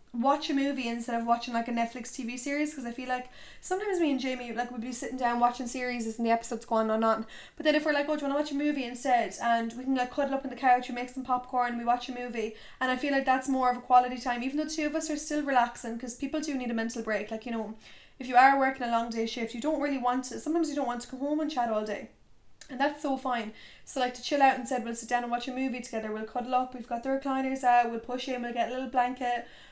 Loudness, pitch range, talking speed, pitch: -30 LUFS, 235-270 Hz, 310 wpm, 250 Hz